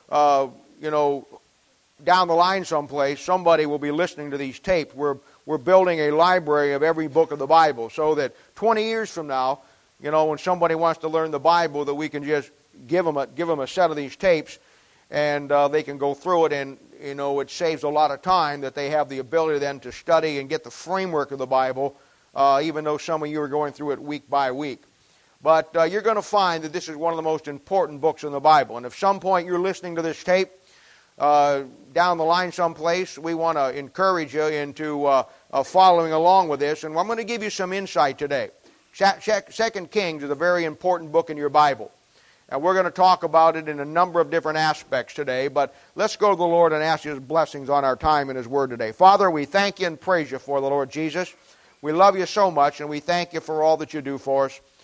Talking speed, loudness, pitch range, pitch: 240 wpm, -22 LUFS, 145-175 Hz, 155 Hz